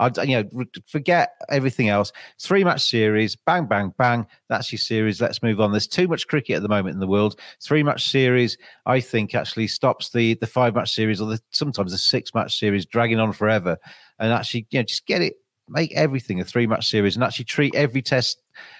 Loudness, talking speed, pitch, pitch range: -21 LUFS, 215 wpm, 115 Hz, 105-130 Hz